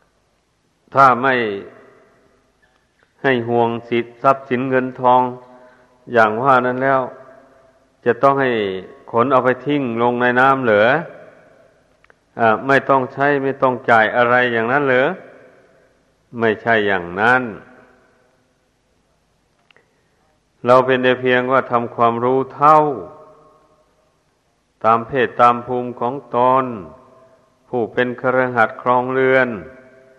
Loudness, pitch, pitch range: -16 LUFS, 125 Hz, 120-130 Hz